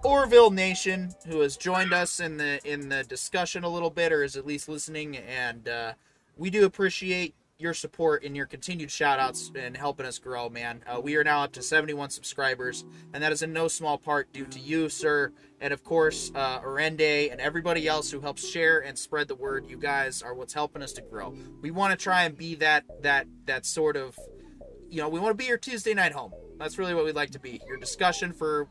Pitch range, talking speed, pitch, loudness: 140-175 Hz, 230 wpm, 155 Hz, -27 LUFS